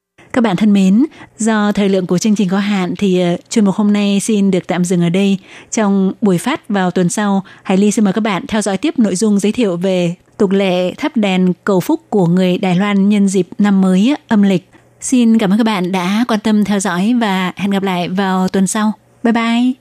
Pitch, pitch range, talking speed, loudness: 200 Hz, 185-220 Hz, 235 wpm, -14 LUFS